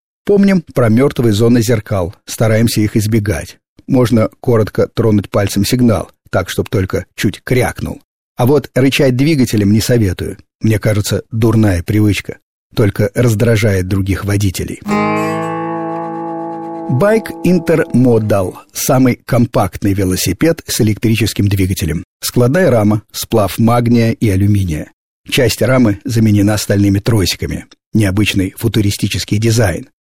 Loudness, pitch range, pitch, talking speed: -14 LUFS, 100-125 Hz, 110 Hz, 110 wpm